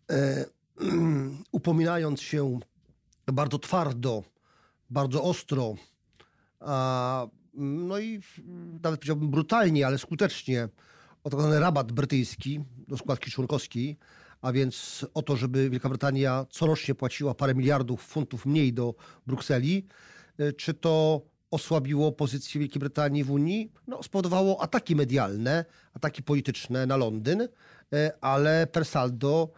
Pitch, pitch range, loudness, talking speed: 145 Hz, 130-160 Hz, -28 LUFS, 110 wpm